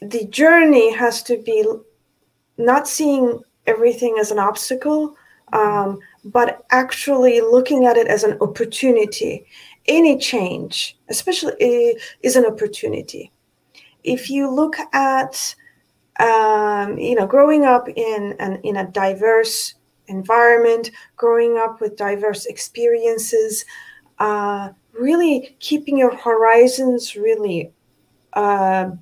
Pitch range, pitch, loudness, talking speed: 215-300 Hz, 240 Hz, -17 LUFS, 110 wpm